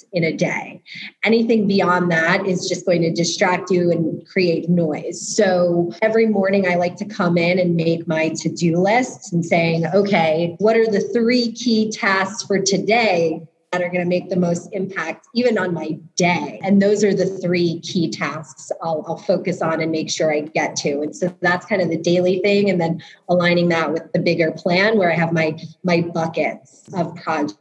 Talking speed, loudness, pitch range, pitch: 200 wpm, -19 LUFS, 165-195 Hz, 175 Hz